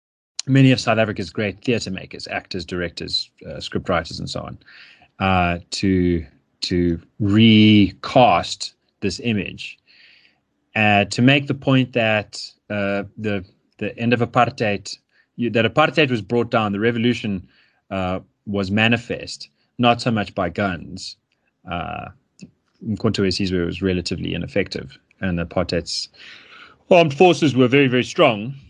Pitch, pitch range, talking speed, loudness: 105 Hz, 95-120 Hz, 135 wpm, -19 LUFS